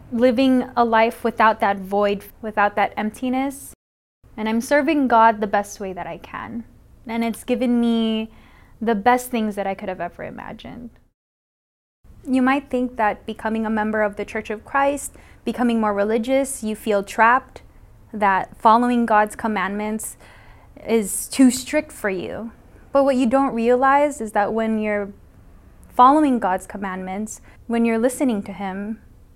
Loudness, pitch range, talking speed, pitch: -20 LUFS, 205-250 Hz, 155 wpm, 225 Hz